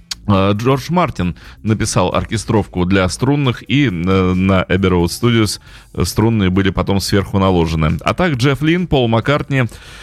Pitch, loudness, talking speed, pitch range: 100 Hz, -15 LUFS, 125 wpm, 90-125 Hz